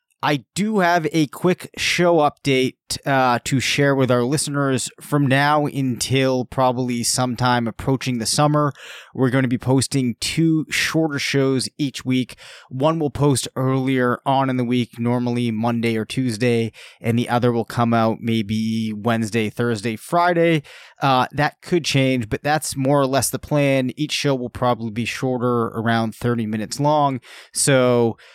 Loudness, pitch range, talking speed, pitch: -20 LUFS, 120-145 Hz, 160 wpm, 130 Hz